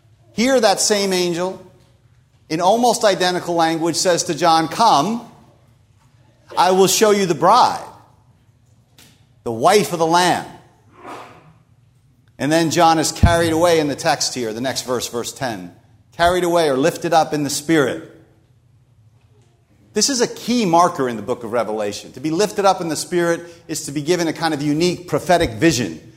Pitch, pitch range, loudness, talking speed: 155 Hz, 120-175 Hz, -17 LUFS, 165 wpm